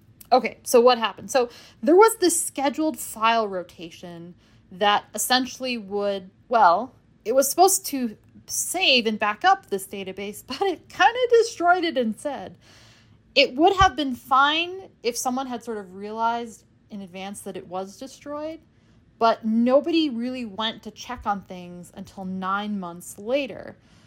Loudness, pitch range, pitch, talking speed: -22 LUFS, 200-280 Hz, 230 Hz, 150 wpm